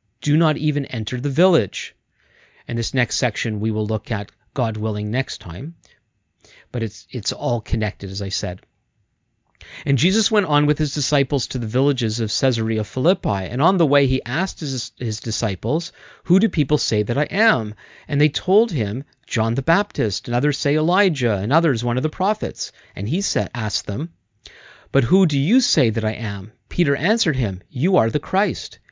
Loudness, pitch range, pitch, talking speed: -20 LUFS, 110-150 Hz, 125 Hz, 190 wpm